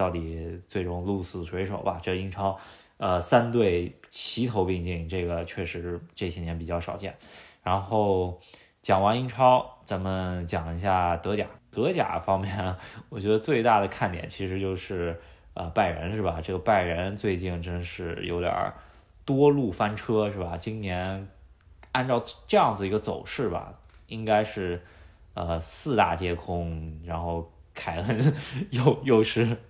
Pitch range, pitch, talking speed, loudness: 85-105 Hz, 95 Hz, 215 characters per minute, -27 LUFS